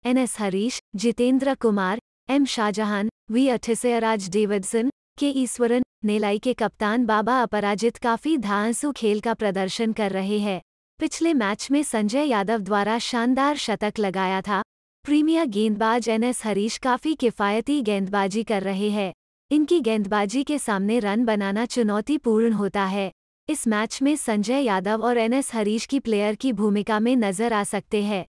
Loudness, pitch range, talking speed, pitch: -23 LUFS, 210-250 Hz, 150 wpm, 225 Hz